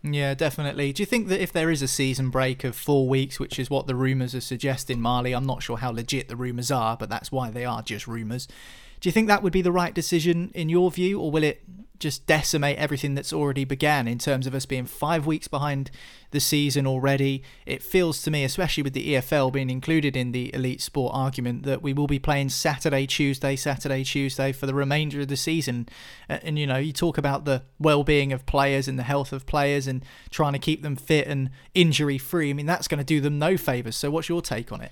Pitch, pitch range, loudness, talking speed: 140 Hz, 130-155 Hz, -25 LUFS, 240 wpm